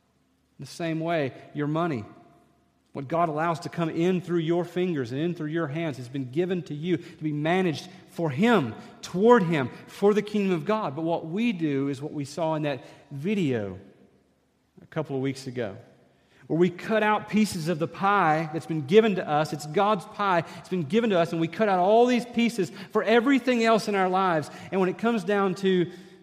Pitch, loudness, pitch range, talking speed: 170 Hz, -26 LUFS, 150-195 Hz, 210 wpm